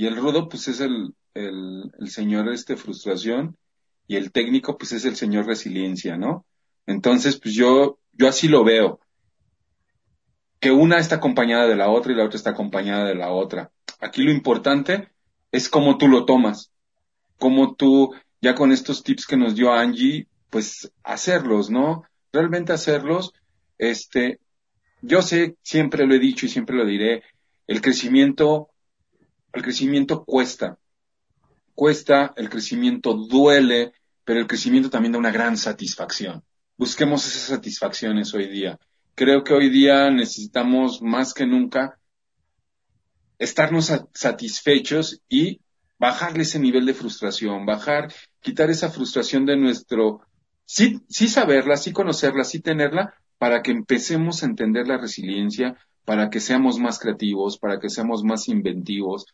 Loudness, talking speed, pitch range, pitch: -20 LUFS, 145 wpm, 110-155 Hz, 130 Hz